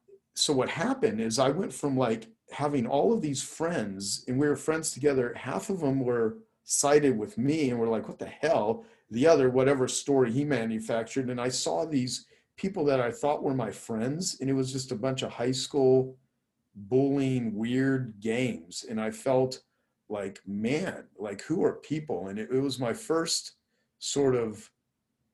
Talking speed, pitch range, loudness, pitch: 180 wpm, 120-145 Hz, -29 LUFS, 130 Hz